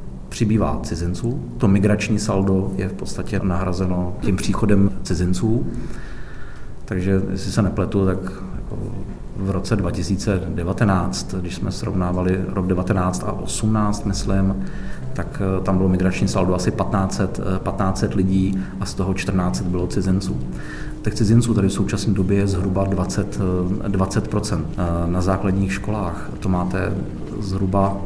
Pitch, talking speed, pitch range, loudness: 95 Hz, 125 wpm, 95-100 Hz, -21 LUFS